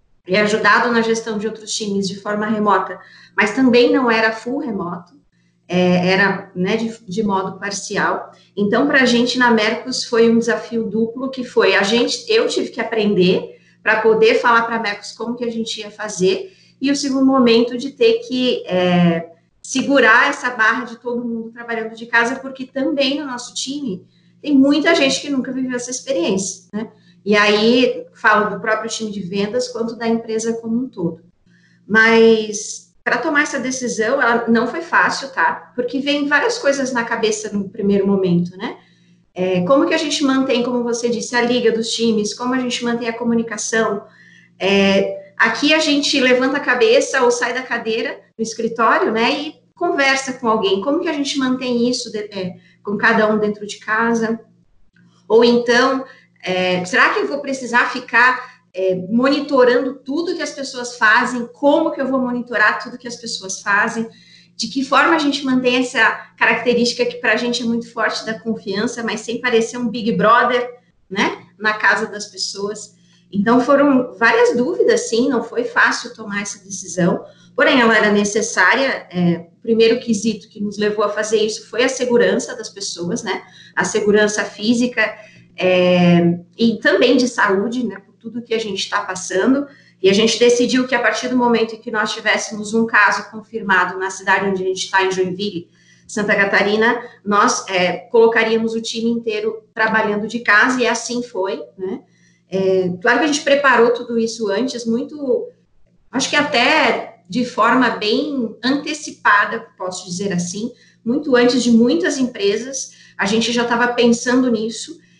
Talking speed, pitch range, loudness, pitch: 175 wpm, 205-245 Hz, -17 LUFS, 230 Hz